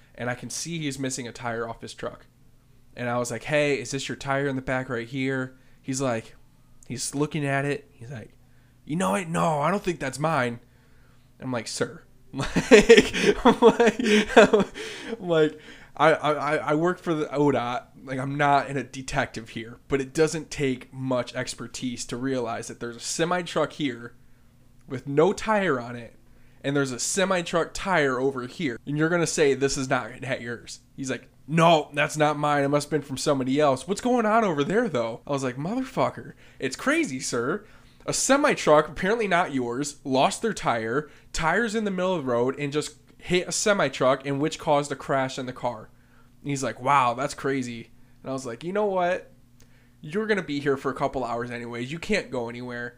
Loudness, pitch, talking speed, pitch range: -25 LUFS, 140 Hz, 205 wpm, 125-165 Hz